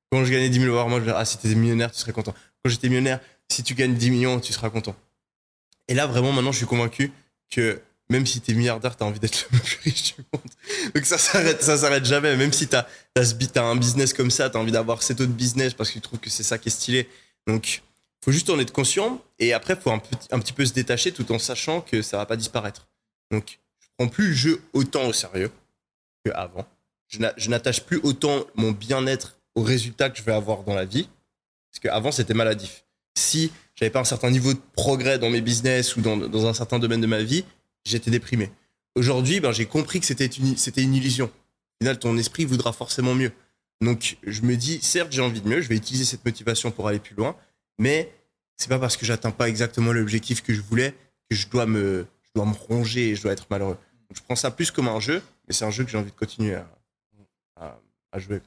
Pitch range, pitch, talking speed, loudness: 110-130 Hz, 120 Hz, 250 wpm, -23 LUFS